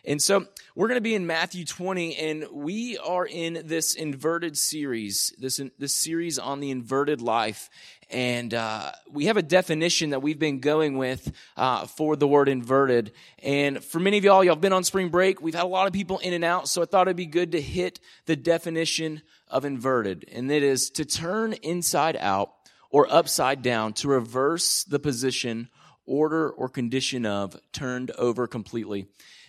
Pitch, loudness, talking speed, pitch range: 150 Hz, -25 LUFS, 190 wpm, 130-170 Hz